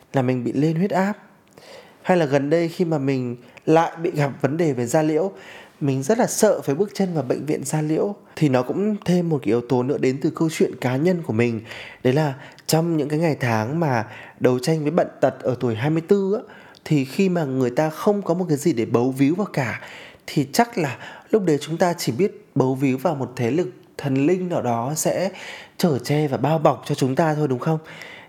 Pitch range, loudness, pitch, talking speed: 135-175 Hz, -22 LUFS, 155 Hz, 240 wpm